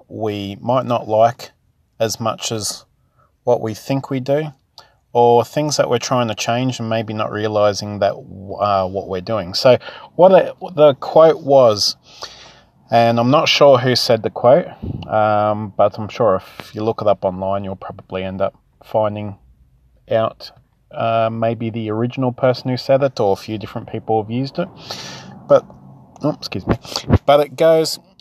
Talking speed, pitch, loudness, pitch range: 170 wpm, 115 Hz, -17 LUFS, 100-130 Hz